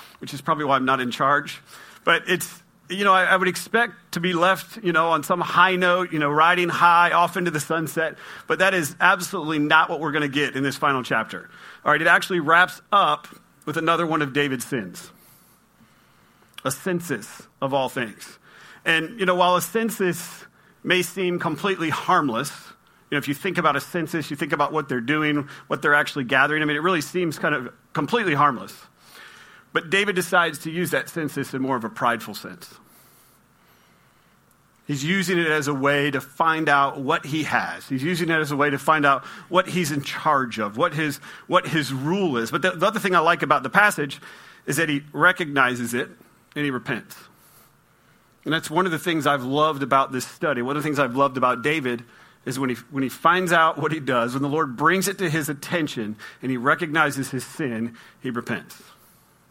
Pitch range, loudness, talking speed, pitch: 140-175 Hz, -22 LUFS, 210 wpm, 155 Hz